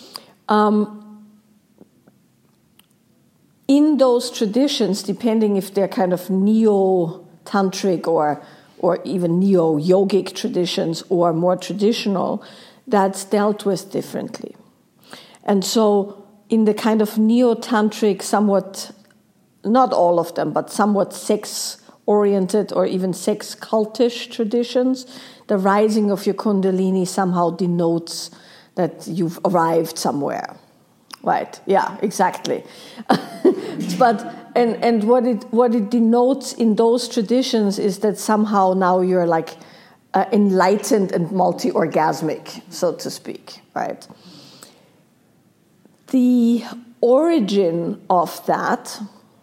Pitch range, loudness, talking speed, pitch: 185-235 Hz, -19 LUFS, 110 wpm, 210 Hz